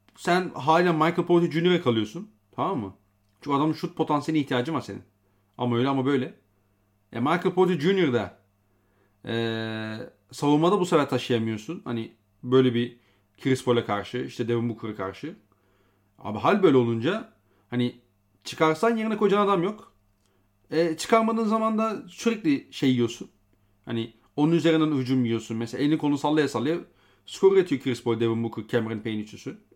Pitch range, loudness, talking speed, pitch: 105-160 Hz, -25 LUFS, 155 wpm, 125 Hz